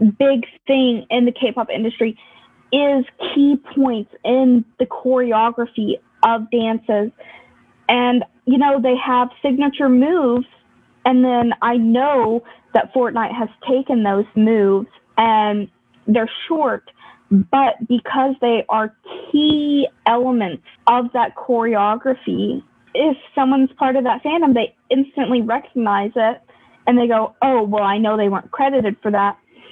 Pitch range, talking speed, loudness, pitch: 225-265 Hz, 135 wpm, -17 LUFS, 245 Hz